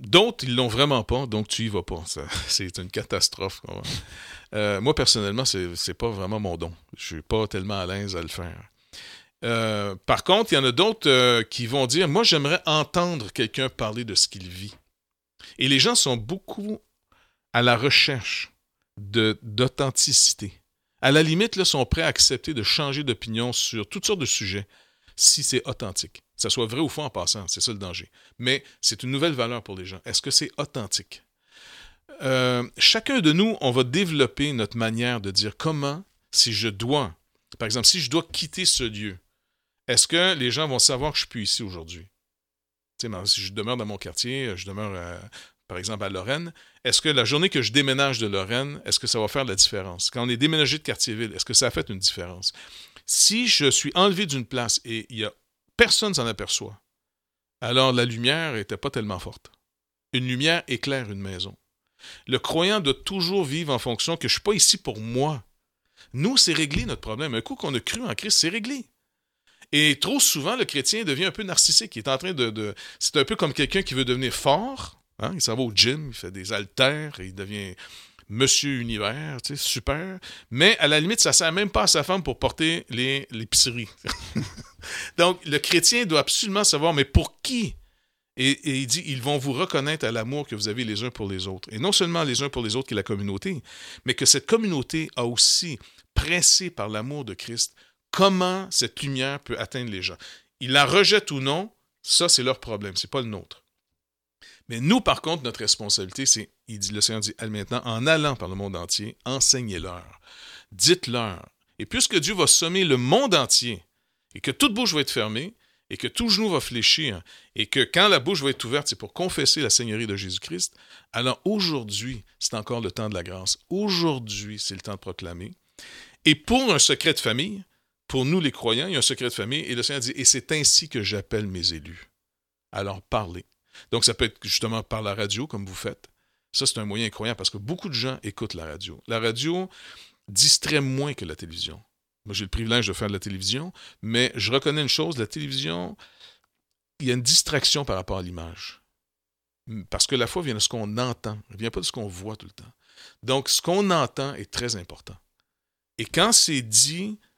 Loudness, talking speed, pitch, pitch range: -22 LUFS, 215 wpm, 120 Hz, 100-150 Hz